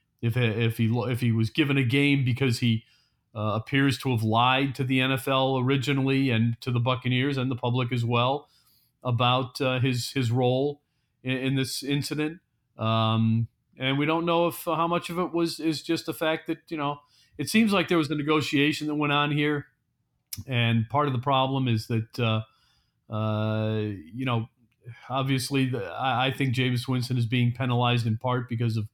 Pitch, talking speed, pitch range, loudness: 130 Hz, 190 wpm, 120-145 Hz, -26 LUFS